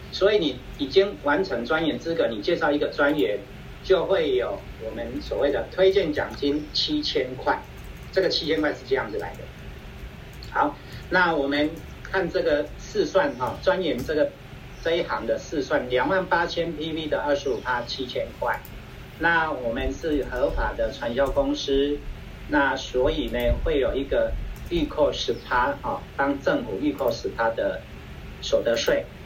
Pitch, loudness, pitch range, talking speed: 140 Hz, -25 LUFS, 115-160 Hz, 235 characters per minute